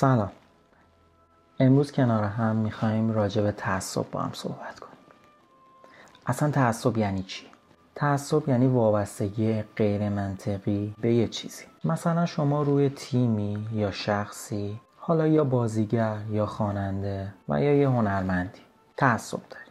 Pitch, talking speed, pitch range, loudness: 110 Hz, 125 wpm, 100-130 Hz, -26 LUFS